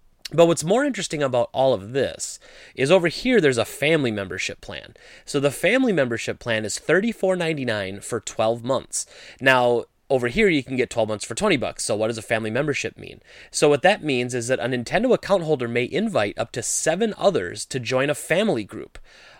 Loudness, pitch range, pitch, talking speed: -22 LUFS, 120-170 Hz, 135 Hz, 200 wpm